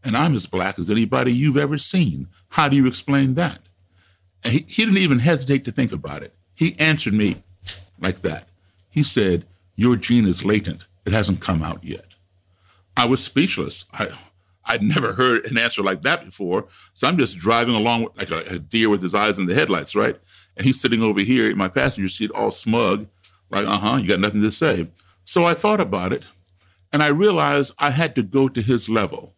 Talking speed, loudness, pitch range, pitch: 210 wpm, -20 LUFS, 95-135 Hz, 105 Hz